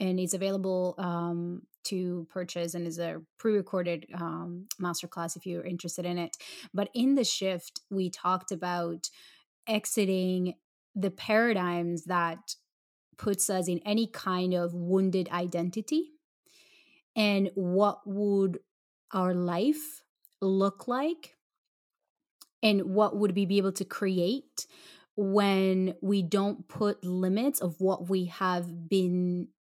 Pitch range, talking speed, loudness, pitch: 175-205 Hz, 120 wpm, -30 LUFS, 190 Hz